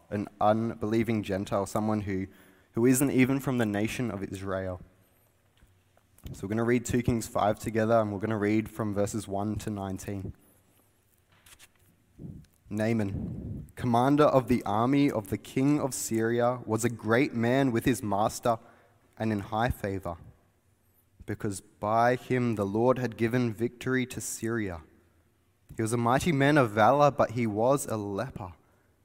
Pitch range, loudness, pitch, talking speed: 100-120 Hz, -28 LUFS, 110 Hz, 155 wpm